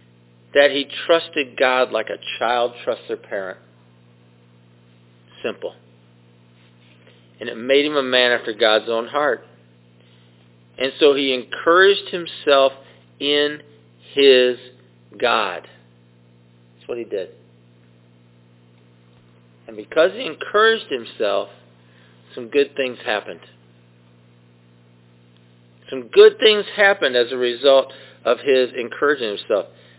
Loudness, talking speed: -18 LUFS, 105 wpm